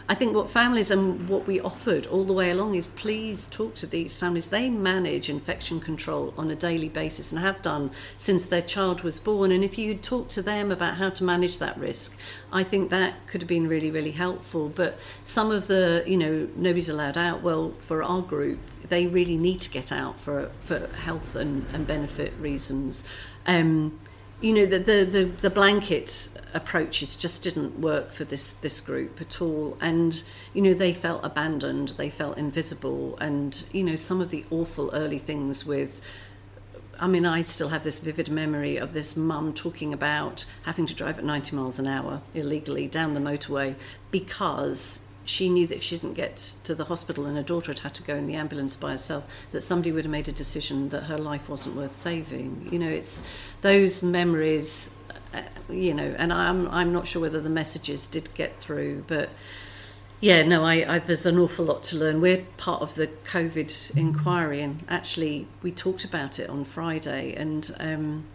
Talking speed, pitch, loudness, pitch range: 195 wpm, 160 Hz, -26 LUFS, 145-180 Hz